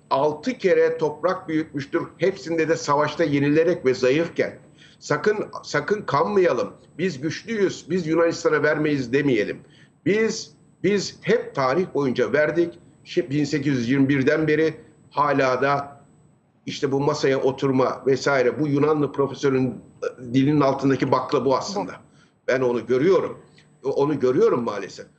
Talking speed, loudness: 115 wpm, -22 LUFS